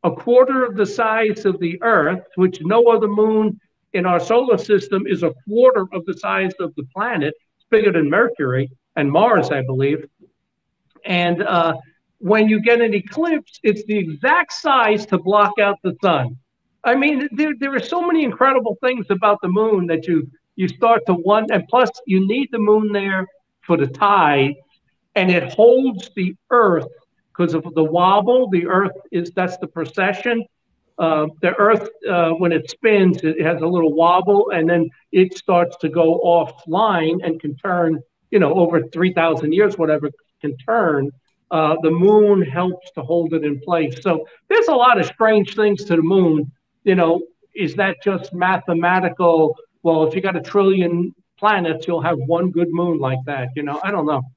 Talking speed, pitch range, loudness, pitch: 185 wpm, 165-215 Hz, -17 LUFS, 185 Hz